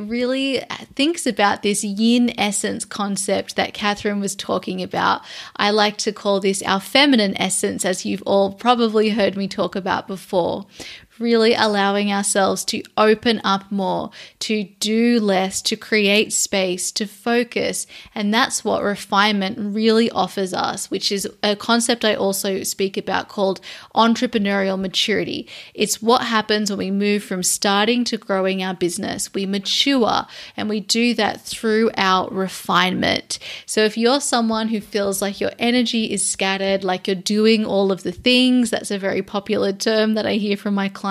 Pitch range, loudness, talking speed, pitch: 195-225 Hz, -19 LUFS, 165 wpm, 205 Hz